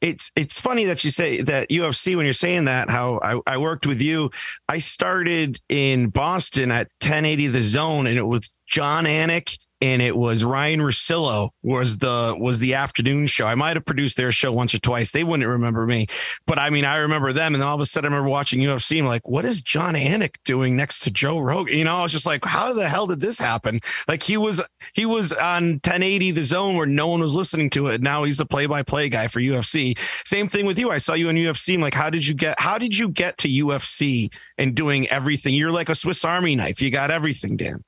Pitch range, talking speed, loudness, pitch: 130-165 Hz, 240 wpm, -21 LUFS, 145 Hz